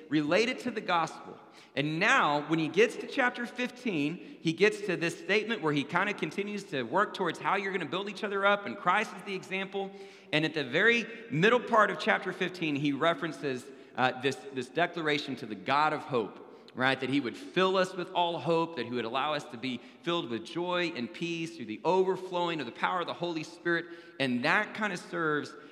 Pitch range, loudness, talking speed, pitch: 150-195 Hz, -30 LUFS, 220 wpm, 170 Hz